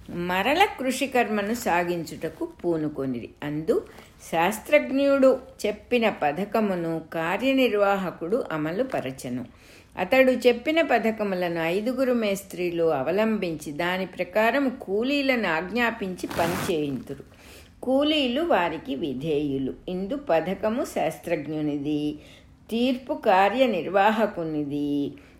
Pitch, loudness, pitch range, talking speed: 195 Hz, -25 LUFS, 160-250 Hz, 70 wpm